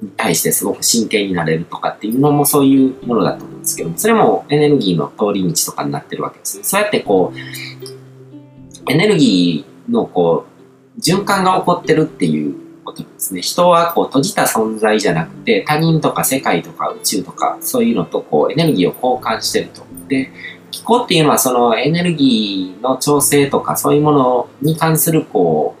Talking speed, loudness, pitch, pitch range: 400 characters per minute, -15 LUFS, 140 Hz, 110-160 Hz